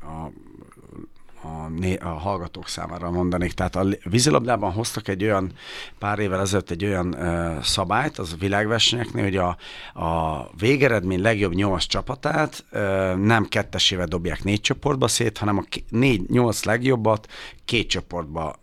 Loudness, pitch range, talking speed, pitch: -23 LUFS, 90-110 Hz, 150 wpm, 95 Hz